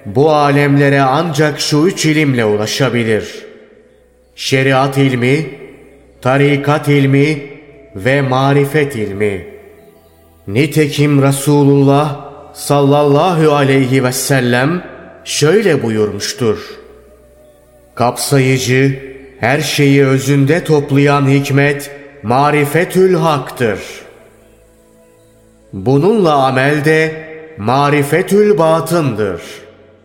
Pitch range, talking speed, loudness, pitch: 130-150 Hz, 70 wpm, -12 LUFS, 140 Hz